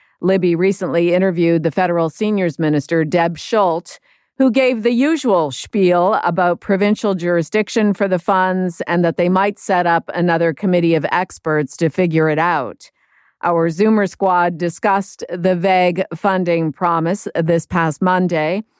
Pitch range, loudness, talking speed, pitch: 170-195 Hz, -16 LUFS, 145 wpm, 180 Hz